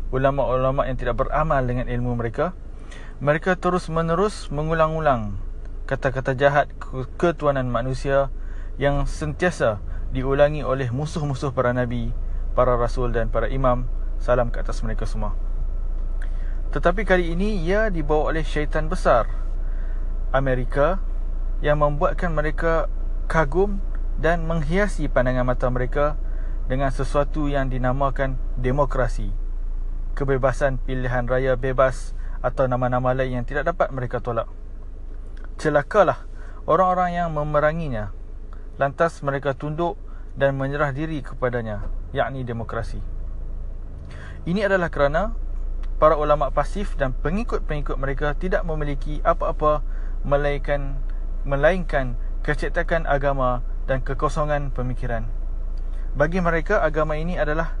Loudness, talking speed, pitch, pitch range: -24 LUFS, 105 wpm, 135 Hz, 115-150 Hz